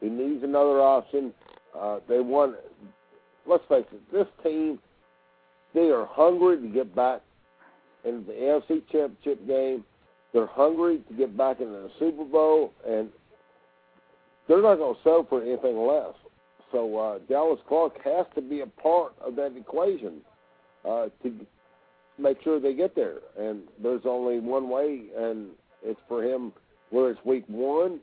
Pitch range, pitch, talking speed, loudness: 105-150 Hz, 130 Hz, 155 wpm, -26 LUFS